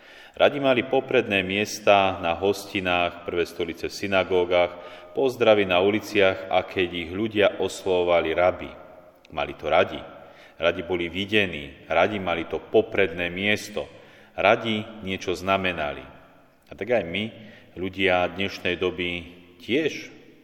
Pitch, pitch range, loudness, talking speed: 95 Hz, 90-105 Hz, -24 LUFS, 120 wpm